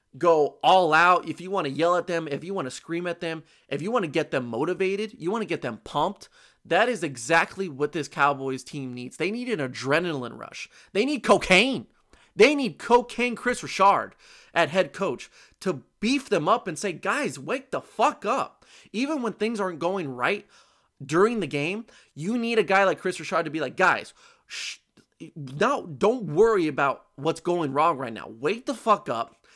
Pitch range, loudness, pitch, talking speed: 155-215 Hz, -25 LUFS, 180 Hz, 200 wpm